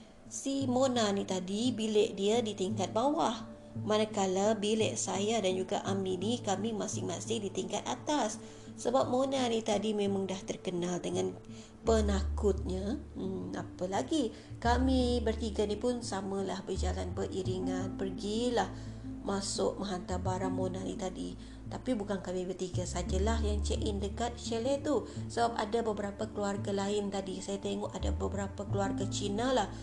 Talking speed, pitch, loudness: 145 wpm, 195 Hz, -33 LUFS